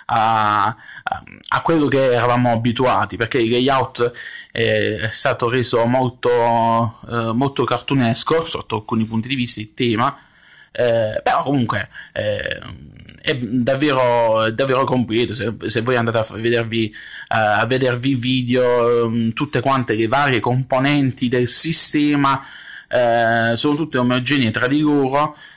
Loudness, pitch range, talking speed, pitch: -18 LUFS, 115-135 Hz, 130 wpm, 120 Hz